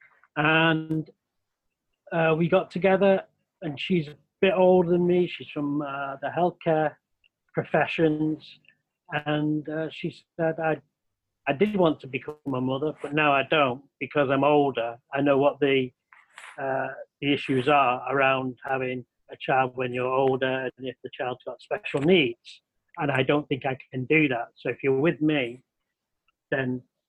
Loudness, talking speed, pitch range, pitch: -25 LUFS, 160 wpm, 130-160 Hz, 145 Hz